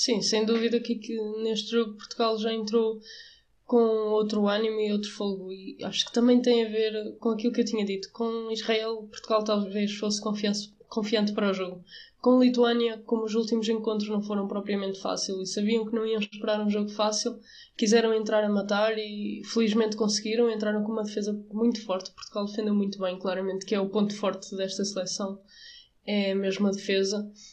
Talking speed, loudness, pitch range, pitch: 185 wpm, -27 LUFS, 205-225 Hz, 215 Hz